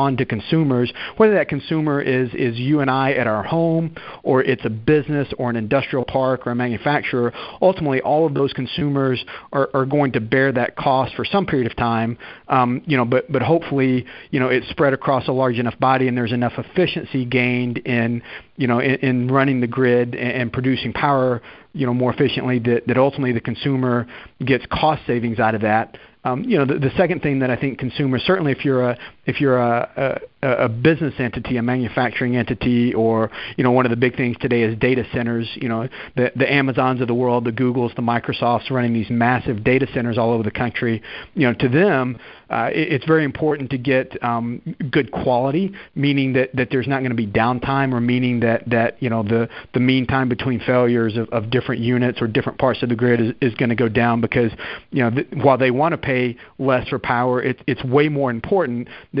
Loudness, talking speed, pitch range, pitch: -19 LUFS, 220 wpm, 120-135 Hz, 130 Hz